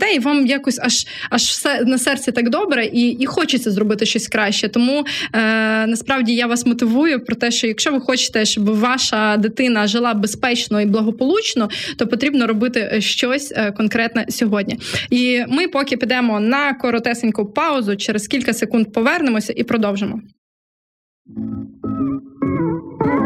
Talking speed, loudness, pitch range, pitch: 140 wpm, -17 LUFS, 220-265 Hz, 240 Hz